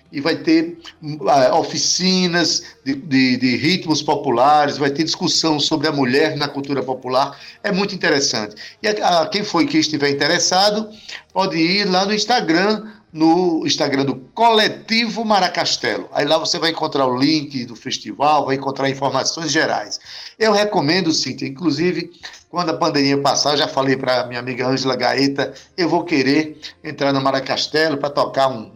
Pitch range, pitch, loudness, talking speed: 140-175 Hz, 155 Hz, -17 LUFS, 165 wpm